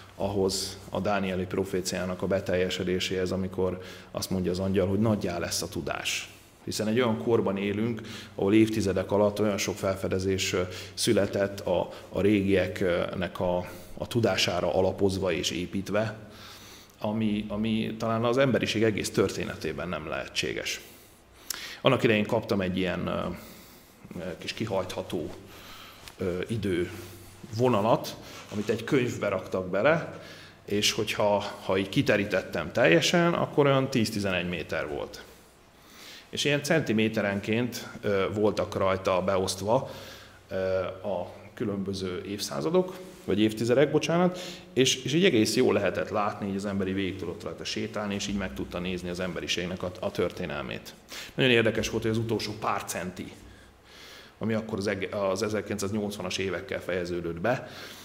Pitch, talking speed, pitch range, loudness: 100 Hz, 125 wpm, 95-110 Hz, -28 LUFS